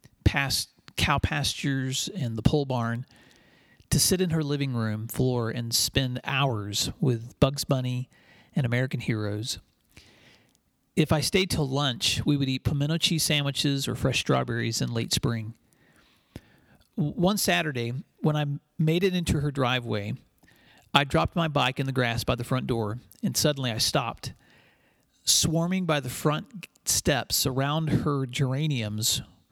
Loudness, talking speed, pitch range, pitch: -26 LUFS, 145 wpm, 120-150 Hz, 135 Hz